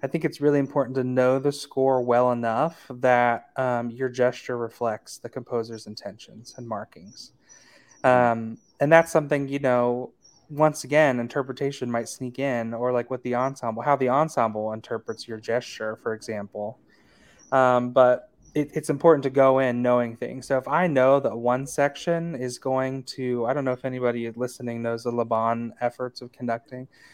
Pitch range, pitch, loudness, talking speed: 120-140 Hz, 125 Hz, -24 LUFS, 170 wpm